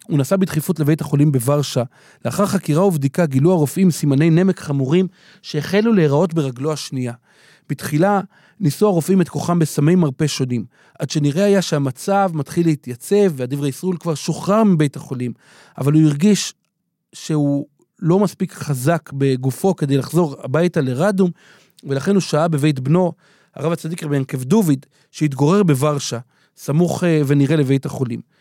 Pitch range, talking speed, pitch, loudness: 145-180 Hz, 140 wpm, 155 Hz, -18 LUFS